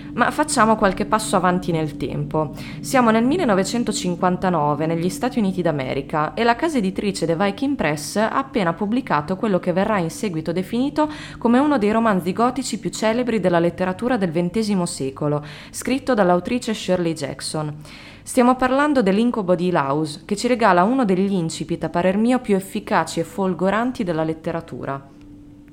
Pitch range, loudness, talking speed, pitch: 165-235 Hz, -20 LUFS, 155 wpm, 190 Hz